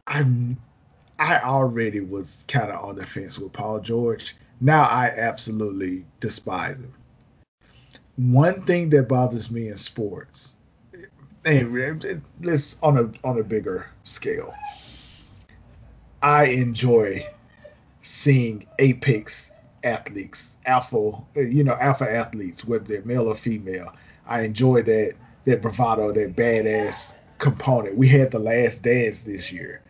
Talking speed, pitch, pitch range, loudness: 125 wpm, 120 Hz, 110-135 Hz, -22 LUFS